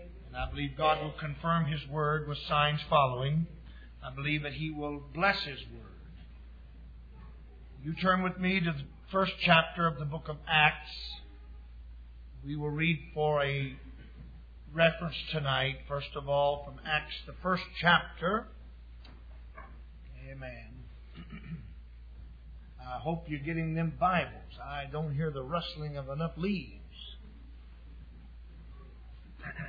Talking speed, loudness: 125 wpm, -31 LUFS